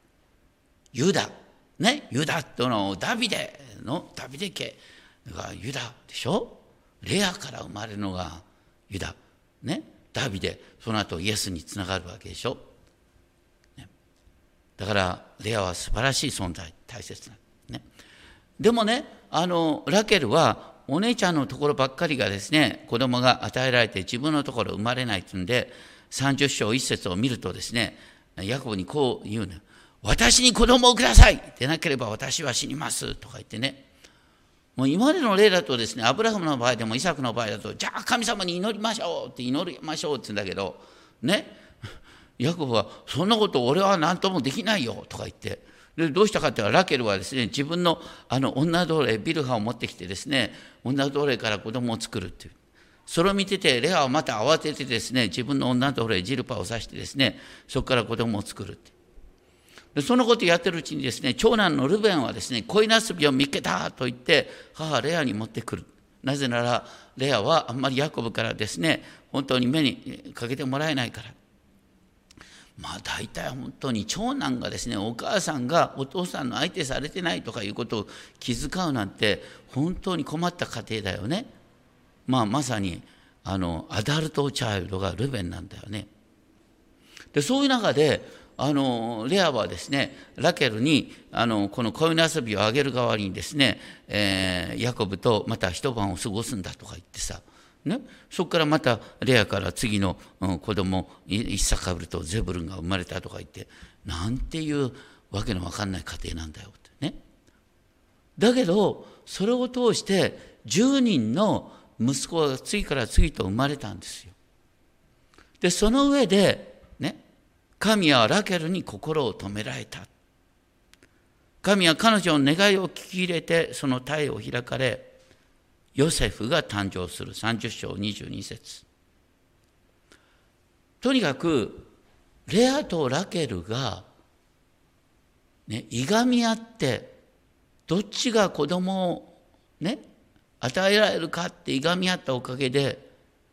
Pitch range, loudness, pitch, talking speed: 100-165 Hz, -25 LUFS, 125 Hz, 310 characters per minute